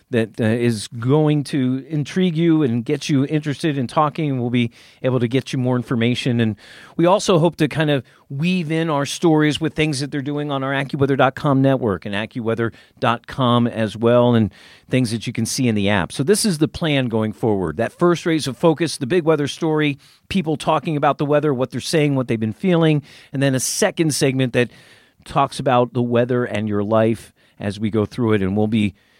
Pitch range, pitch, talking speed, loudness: 115-155 Hz, 135 Hz, 215 wpm, -19 LUFS